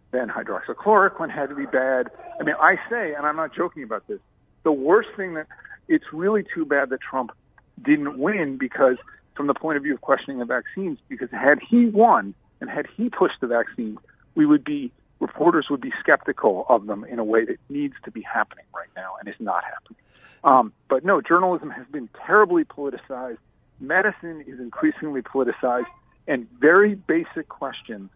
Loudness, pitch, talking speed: -22 LUFS, 165 Hz, 185 wpm